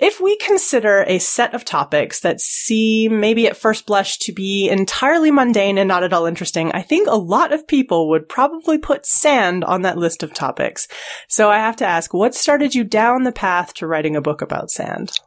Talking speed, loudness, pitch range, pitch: 210 wpm, -16 LUFS, 180-270 Hz, 220 Hz